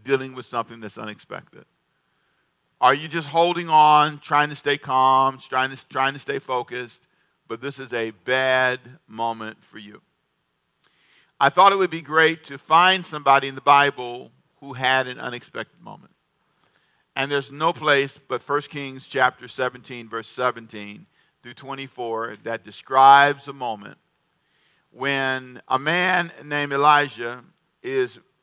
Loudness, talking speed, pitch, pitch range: -21 LUFS, 145 wpm, 135 Hz, 120-145 Hz